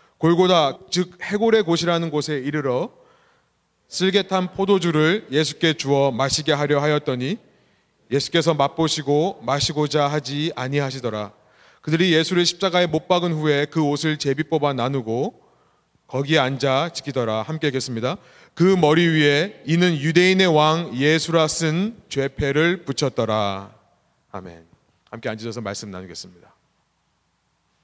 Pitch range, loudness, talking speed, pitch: 135-170 Hz, -20 LUFS, 295 characters per minute, 150 Hz